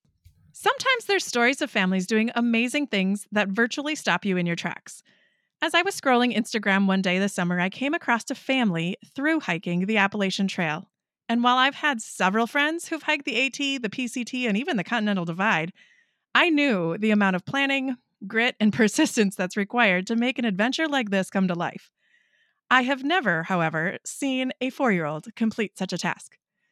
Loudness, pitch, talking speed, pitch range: -24 LUFS, 225 Hz, 190 wpm, 195-265 Hz